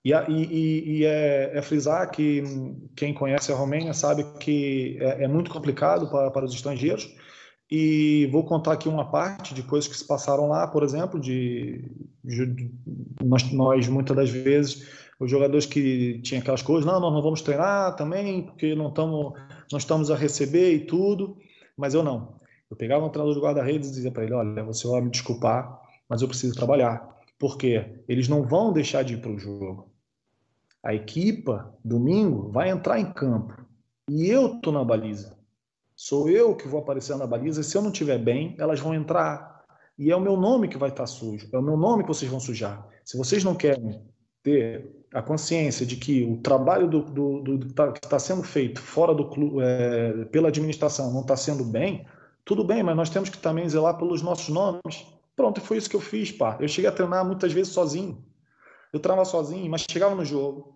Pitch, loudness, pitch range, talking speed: 145 Hz, -25 LUFS, 130-160 Hz, 200 wpm